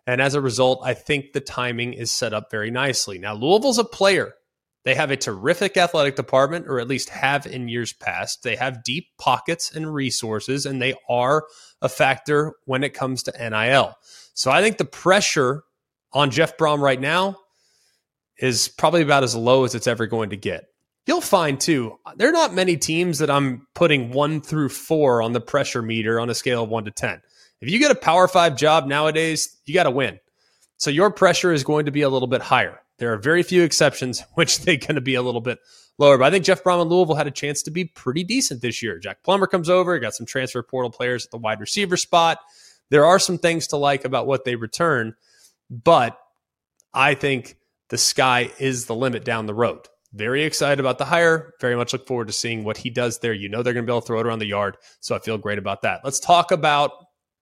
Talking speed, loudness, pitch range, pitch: 225 wpm, -20 LUFS, 120-160 Hz, 135 Hz